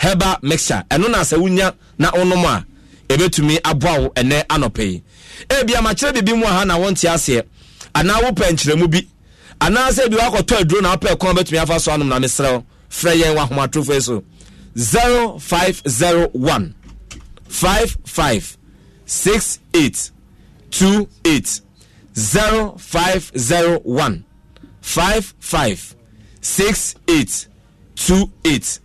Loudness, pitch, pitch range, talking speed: -16 LUFS, 170 Hz, 135-190 Hz, 145 wpm